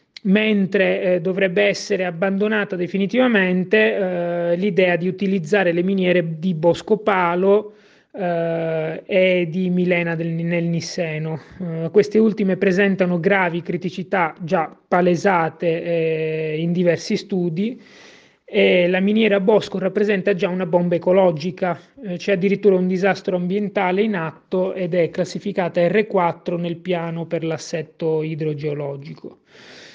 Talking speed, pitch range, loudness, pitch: 120 wpm, 170-200 Hz, -19 LUFS, 185 Hz